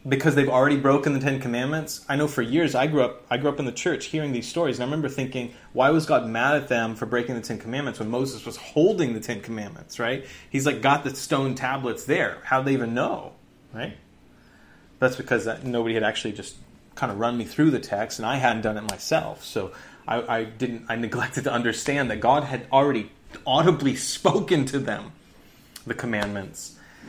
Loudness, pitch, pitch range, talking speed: -24 LUFS, 130 Hz, 115-140 Hz, 215 wpm